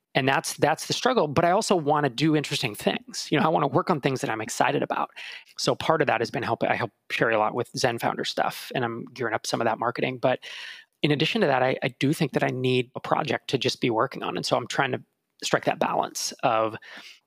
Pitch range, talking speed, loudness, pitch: 130-155 Hz, 270 wpm, -25 LUFS, 140 Hz